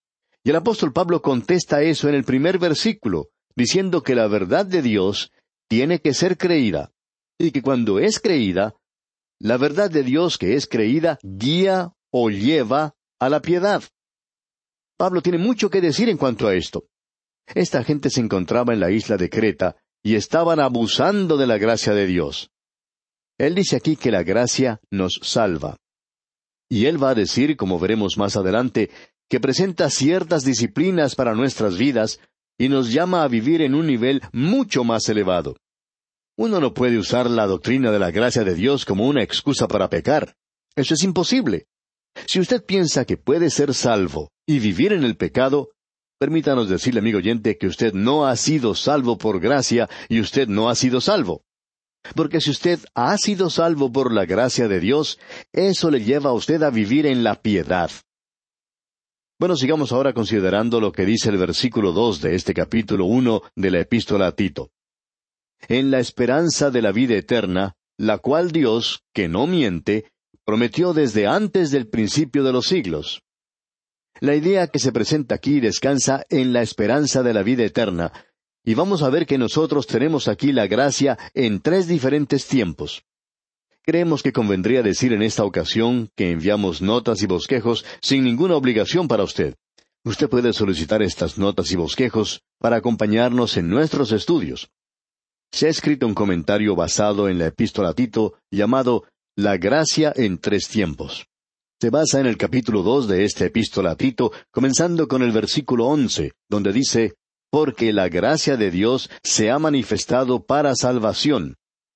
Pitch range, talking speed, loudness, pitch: 110-150 Hz, 165 wpm, -20 LUFS, 125 Hz